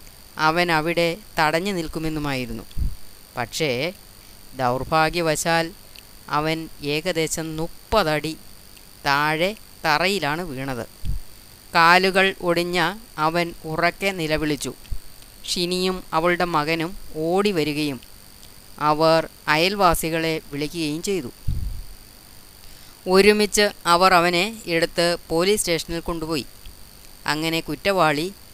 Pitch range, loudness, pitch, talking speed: 130-175 Hz, -21 LUFS, 160 Hz, 75 wpm